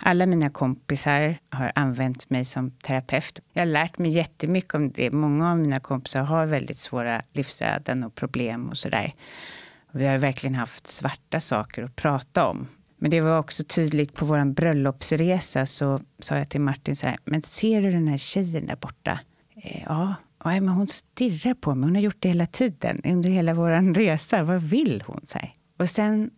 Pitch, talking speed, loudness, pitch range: 155 Hz, 185 wpm, -24 LUFS, 135-175 Hz